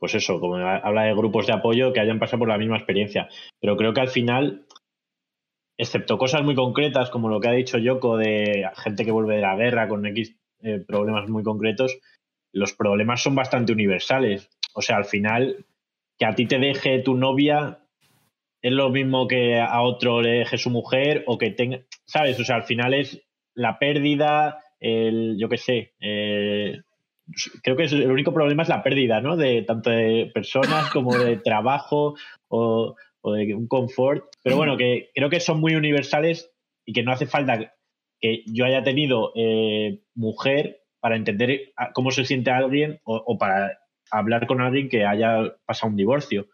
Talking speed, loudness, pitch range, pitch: 185 wpm, -22 LUFS, 110-135 Hz, 120 Hz